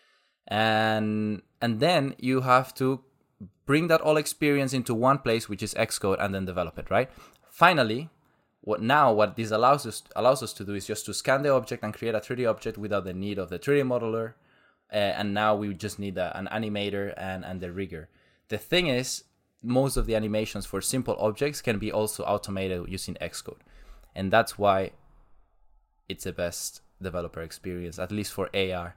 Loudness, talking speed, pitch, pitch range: -27 LUFS, 190 wpm, 105 Hz, 95-125 Hz